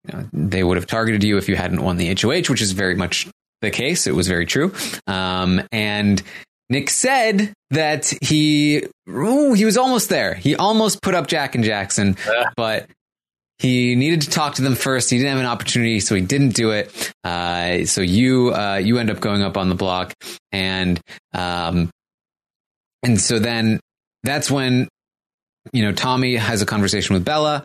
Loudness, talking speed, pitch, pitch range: -19 LUFS, 185 wpm, 115 Hz, 95-140 Hz